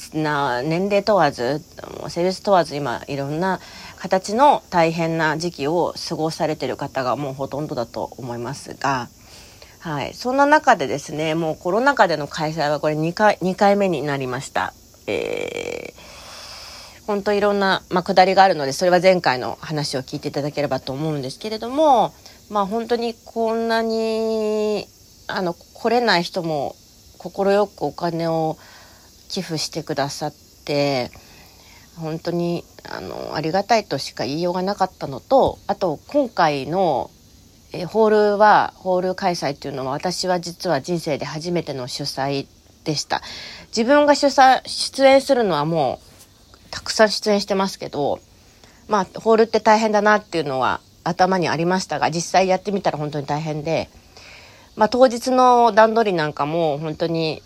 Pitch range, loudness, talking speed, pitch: 145-210 Hz, -20 LUFS, 310 characters per minute, 170 Hz